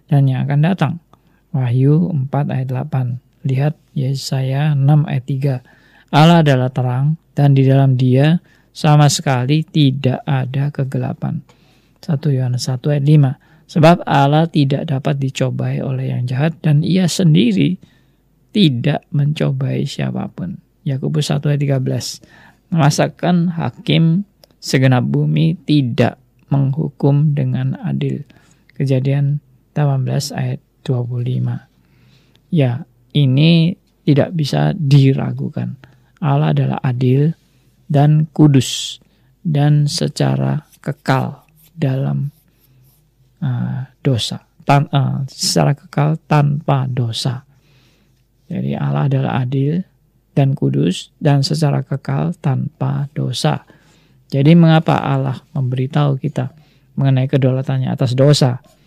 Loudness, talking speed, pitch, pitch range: -16 LUFS, 105 wpm, 140 Hz, 130-150 Hz